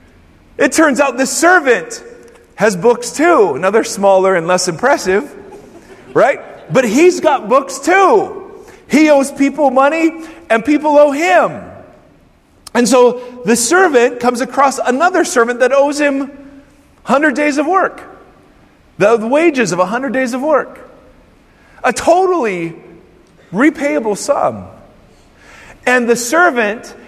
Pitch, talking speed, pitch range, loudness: 275 Hz, 125 wpm, 240-325 Hz, -12 LUFS